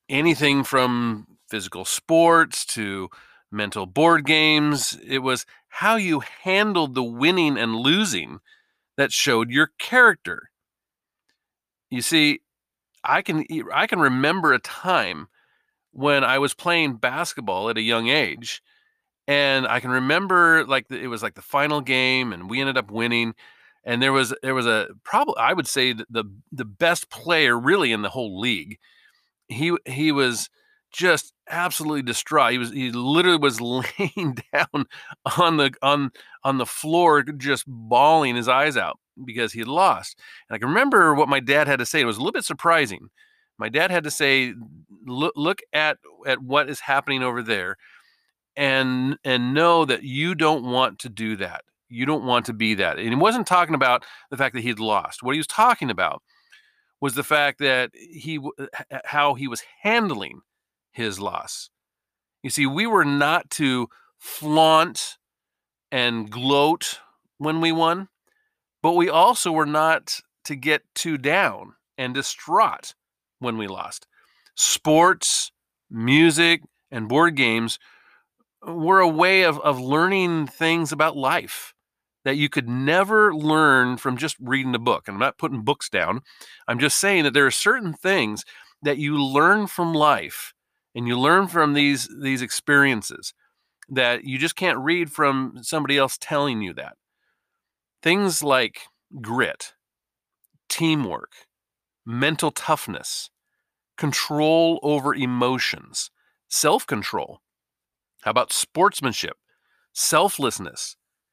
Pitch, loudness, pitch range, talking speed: 145 Hz, -21 LUFS, 125-165 Hz, 150 wpm